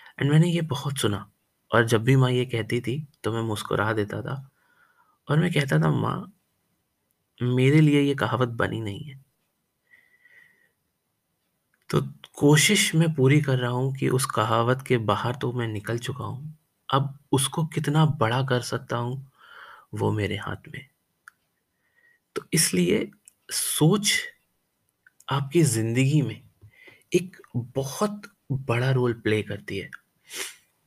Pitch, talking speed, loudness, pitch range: 135 Hz, 135 wpm, -24 LUFS, 115-155 Hz